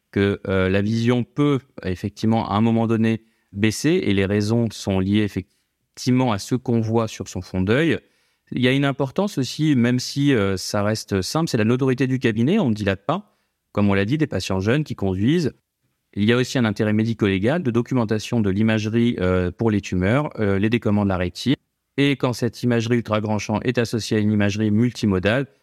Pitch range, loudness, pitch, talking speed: 100-125 Hz, -21 LUFS, 115 Hz, 205 wpm